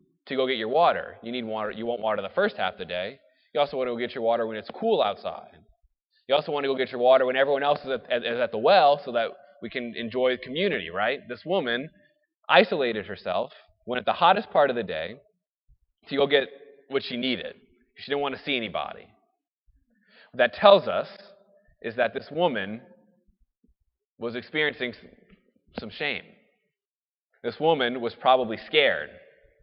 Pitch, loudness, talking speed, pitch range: 135 Hz, -25 LUFS, 190 wpm, 125-200 Hz